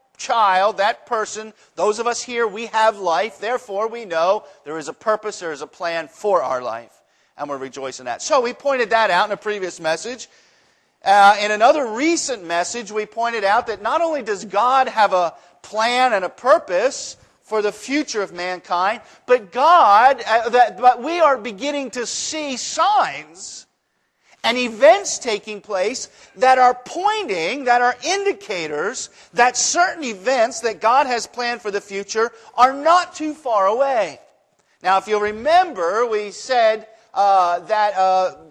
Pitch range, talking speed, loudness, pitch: 200-260 Hz, 160 wpm, -18 LUFS, 230 Hz